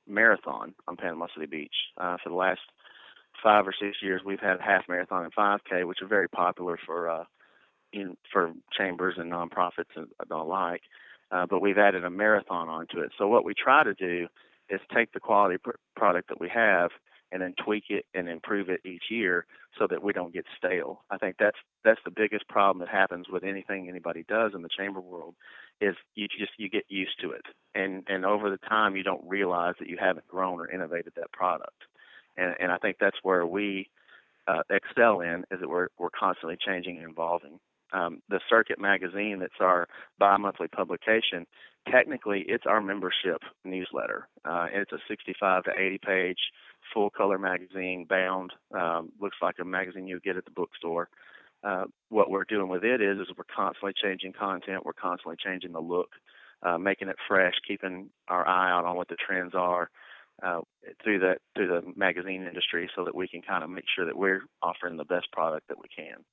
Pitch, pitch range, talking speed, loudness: 95 Hz, 90-100 Hz, 200 wpm, -29 LUFS